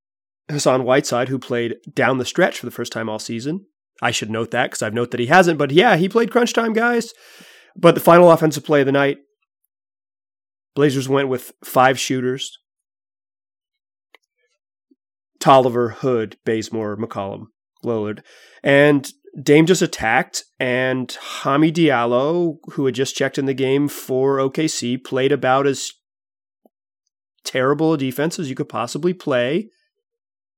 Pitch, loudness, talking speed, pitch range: 135 Hz, -18 LUFS, 145 wpm, 120-160 Hz